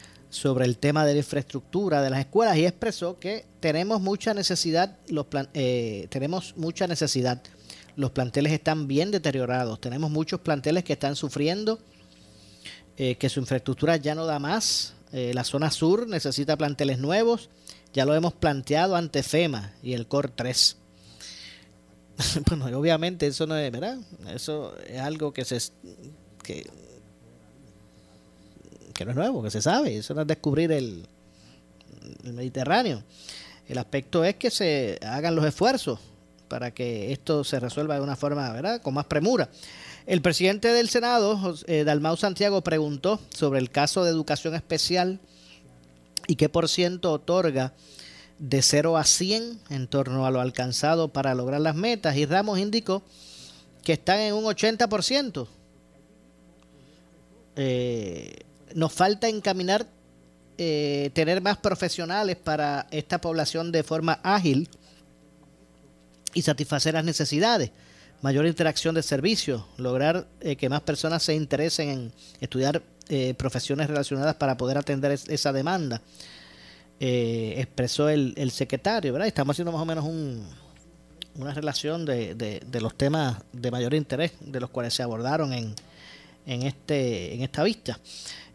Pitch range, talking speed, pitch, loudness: 125-165 Hz, 145 wpm, 145 Hz, -26 LUFS